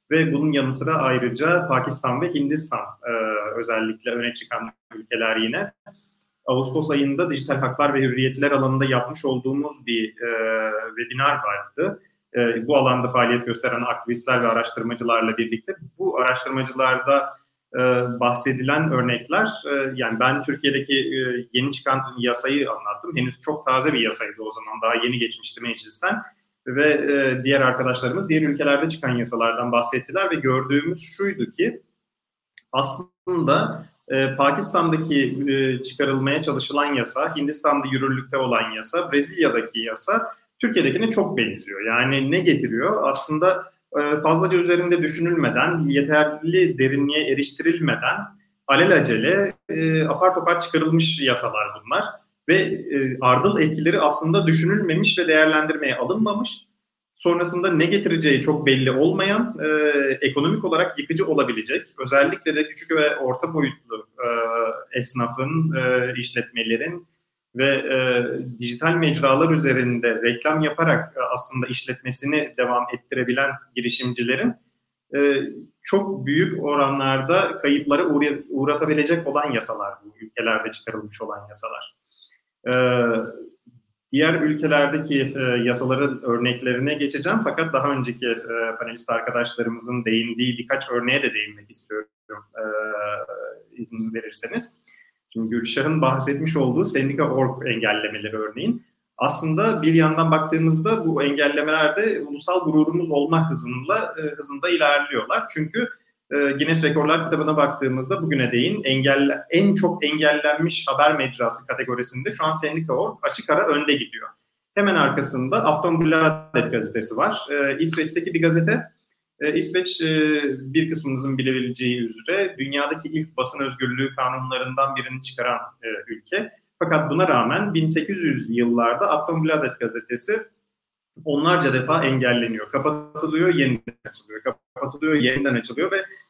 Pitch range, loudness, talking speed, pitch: 125-160 Hz, -21 LUFS, 120 wpm, 140 Hz